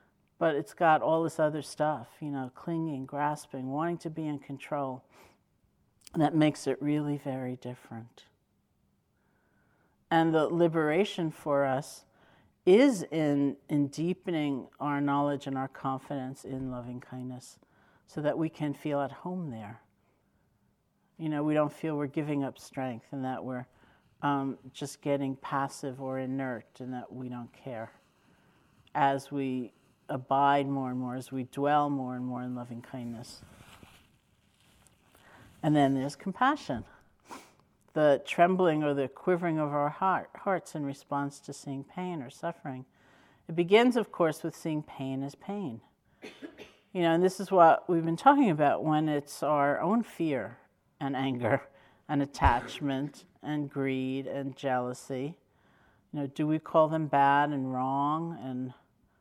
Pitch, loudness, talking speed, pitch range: 140 Hz, -30 LUFS, 150 wpm, 130-155 Hz